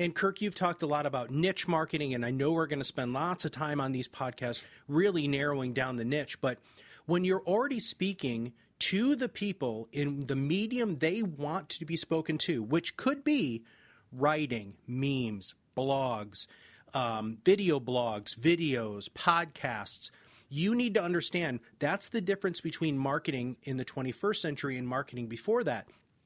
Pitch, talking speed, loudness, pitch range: 145 Hz, 160 wpm, -32 LUFS, 125-175 Hz